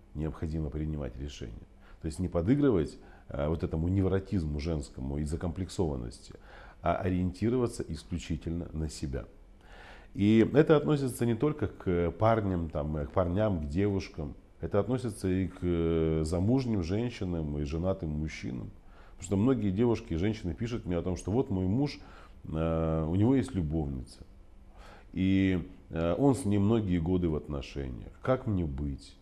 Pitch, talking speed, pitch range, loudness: 90 Hz, 140 wpm, 80-100 Hz, -31 LUFS